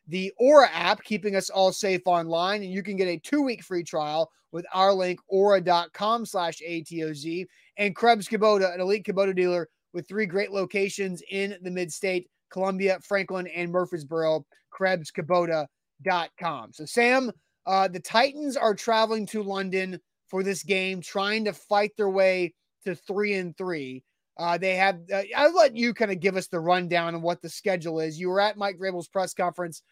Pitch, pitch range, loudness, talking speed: 190 Hz, 175-200 Hz, -26 LUFS, 180 wpm